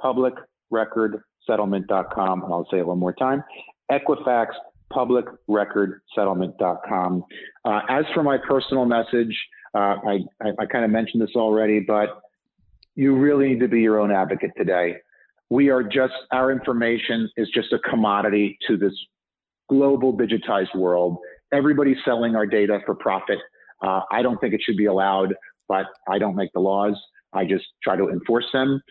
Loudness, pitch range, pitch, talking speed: -22 LUFS, 95-125 Hz, 110 Hz, 165 wpm